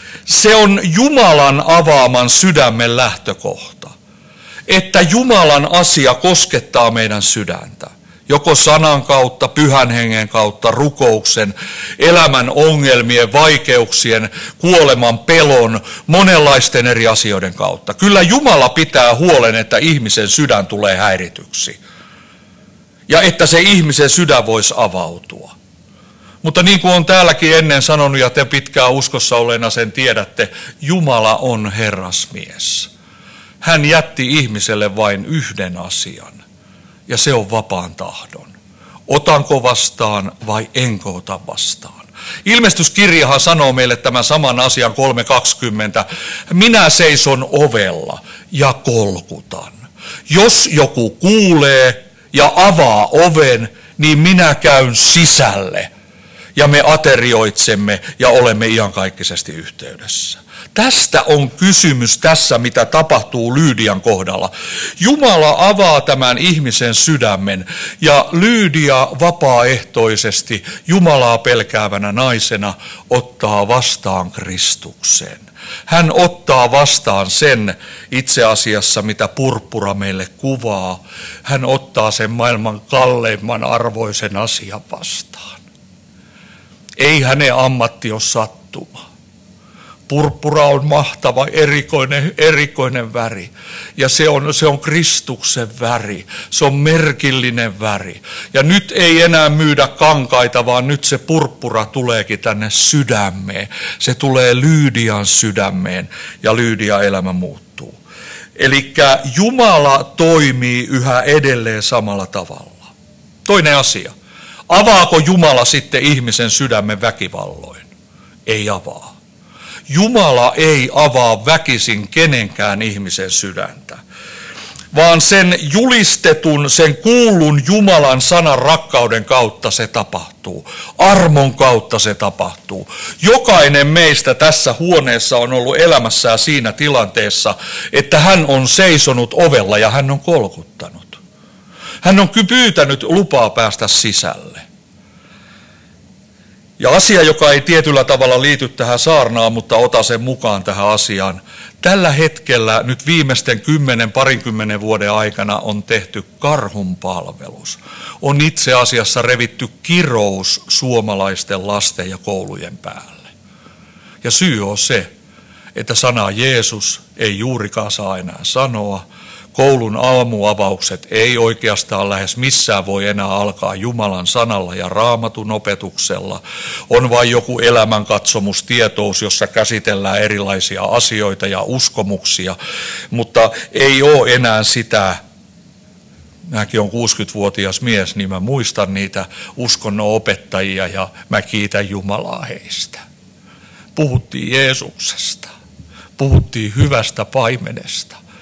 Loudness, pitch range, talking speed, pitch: -11 LUFS, 105-150 Hz, 105 wpm, 125 Hz